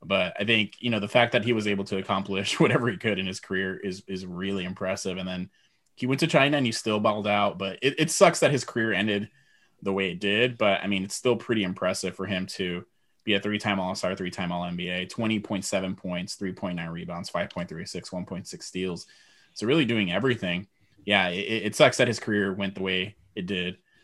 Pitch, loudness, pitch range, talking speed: 100 Hz, -26 LUFS, 95-110 Hz, 215 wpm